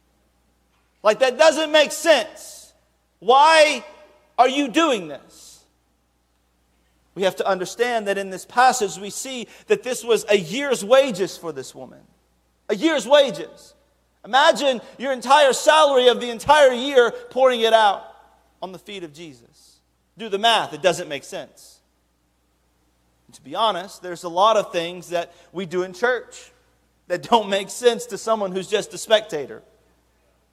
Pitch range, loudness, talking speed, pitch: 165-260 Hz, -19 LUFS, 155 wpm, 205 Hz